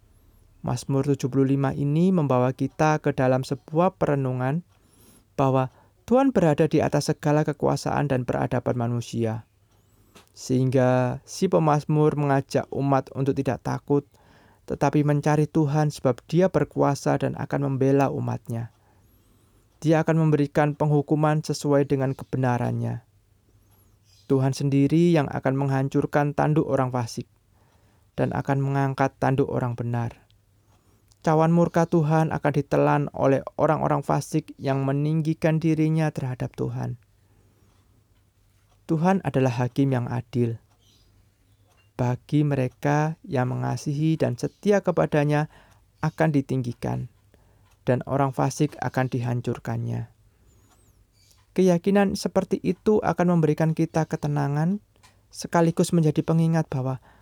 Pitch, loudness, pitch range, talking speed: 135 Hz, -24 LUFS, 110-150 Hz, 105 wpm